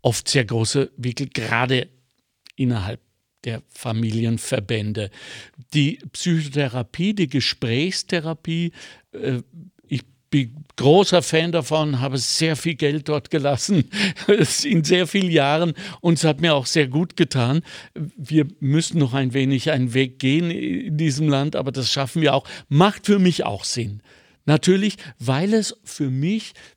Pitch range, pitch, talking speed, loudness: 130-170 Hz, 145 Hz, 135 wpm, -21 LUFS